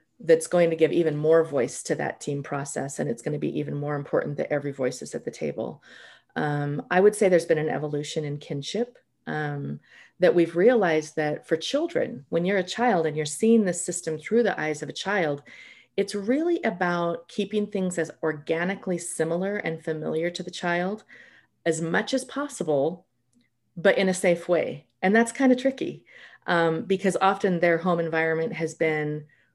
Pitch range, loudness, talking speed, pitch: 155-200 Hz, -25 LUFS, 190 wpm, 170 Hz